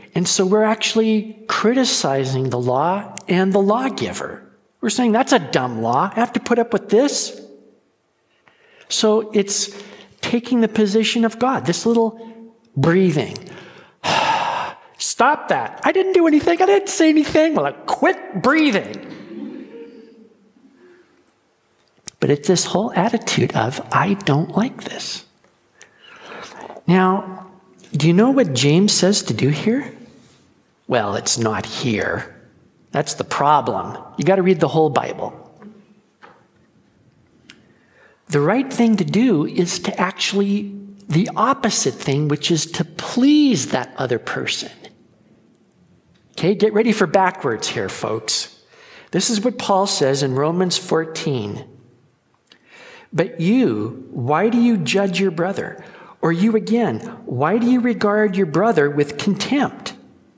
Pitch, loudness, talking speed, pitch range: 205 Hz, -18 LUFS, 130 wpm, 170-235 Hz